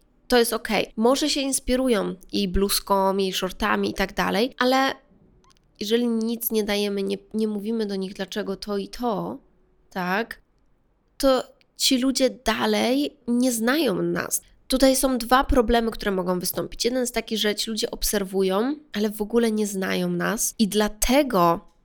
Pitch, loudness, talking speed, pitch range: 215 Hz, -23 LUFS, 155 wpm, 195-245 Hz